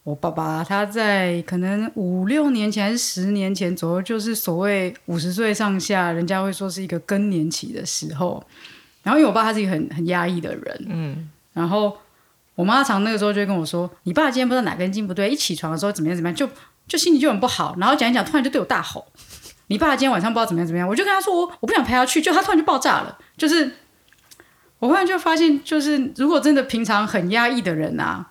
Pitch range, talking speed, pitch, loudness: 180-270 Hz, 370 characters per minute, 210 Hz, -20 LUFS